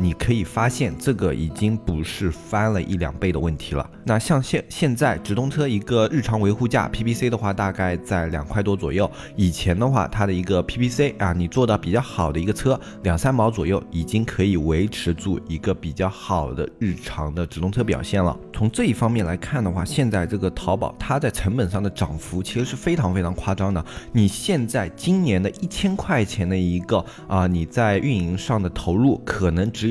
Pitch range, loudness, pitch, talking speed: 90-115 Hz, -22 LUFS, 100 Hz, 310 characters per minute